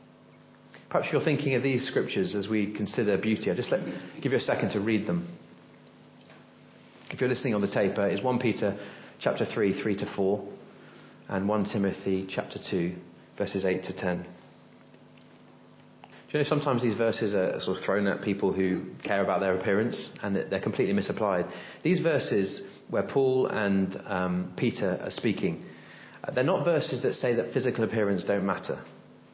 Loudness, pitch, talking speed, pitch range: -28 LUFS, 100 Hz, 170 wpm, 95-110 Hz